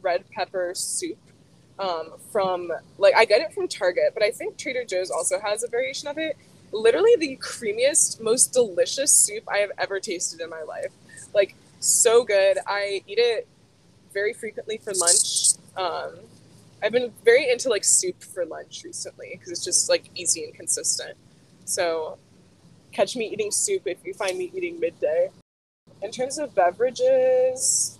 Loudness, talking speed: -22 LUFS, 165 wpm